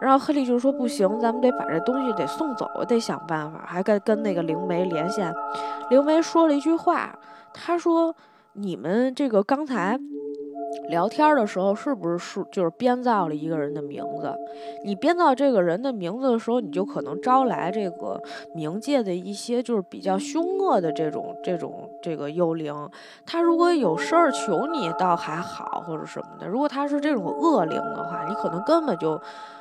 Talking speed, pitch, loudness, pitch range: 280 characters per minute, 230 Hz, -24 LUFS, 175-280 Hz